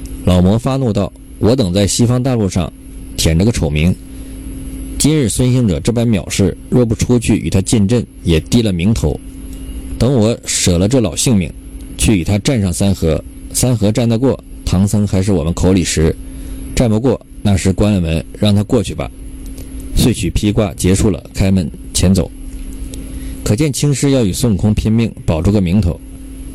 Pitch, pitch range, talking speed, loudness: 100 Hz, 85-115 Hz, 245 characters per minute, -14 LUFS